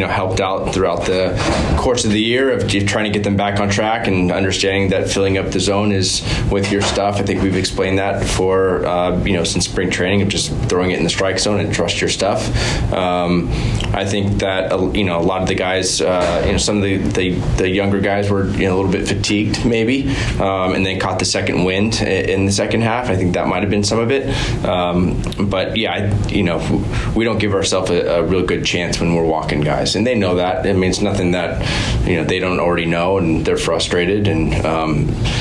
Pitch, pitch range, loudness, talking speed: 95 Hz, 90-105 Hz, -16 LUFS, 240 wpm